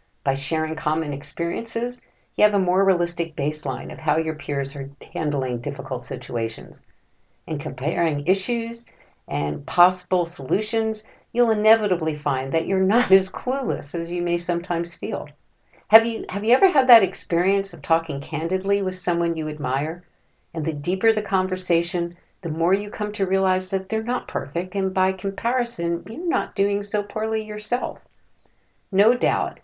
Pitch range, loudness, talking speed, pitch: 160-210 Hz, -23 LUFS, 160 wpm, 180 Hz